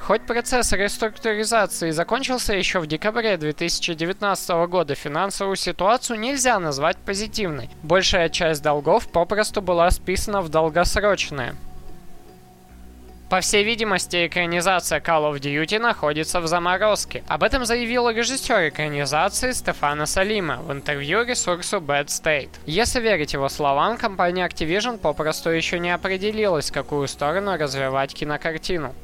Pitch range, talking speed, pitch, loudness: 150-210 Hz, 120 wpm, 180 Hz, -21 LUFS